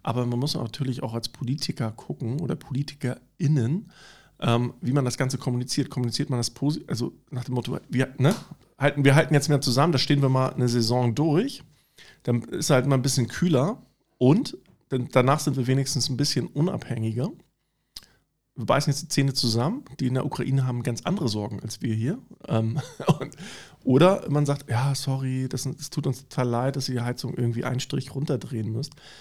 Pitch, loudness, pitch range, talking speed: 130 Hz, -25 LUFS, 125-145 Hz, 190 wpm